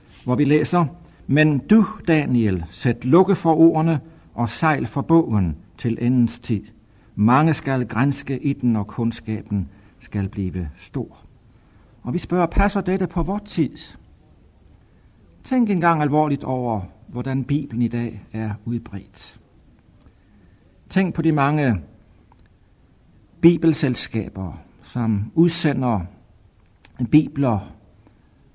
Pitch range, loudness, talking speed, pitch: 100-150 Hz, -21 LUFS, 110 wpm, 120 Hz